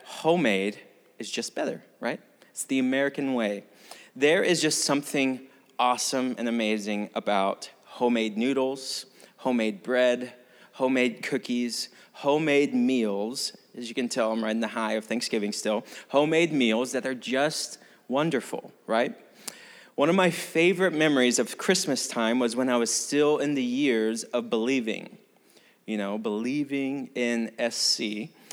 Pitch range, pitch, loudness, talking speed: 115-140 Hz, 125 Hz, -26 LUFS, 140 wpm